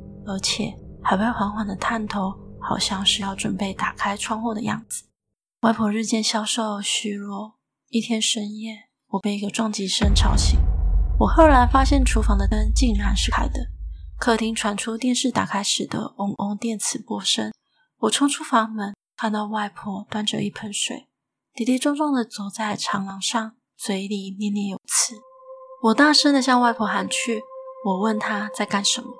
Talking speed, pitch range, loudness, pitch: 245 characters per minute, 200-235 Hz, -22 LUFS, 215 Hz